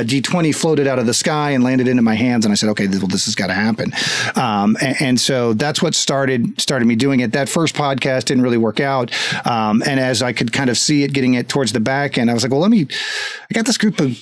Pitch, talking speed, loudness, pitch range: 135 Hz, 275 wpm, -16 LUFS, 120-150 Hz